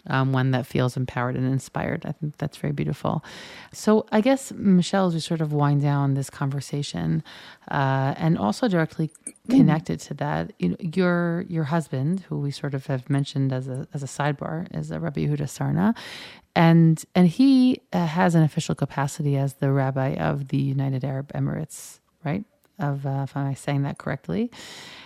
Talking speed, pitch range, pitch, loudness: 180 wpm, 135-170 Hz, 145 Hz, -24 LUFS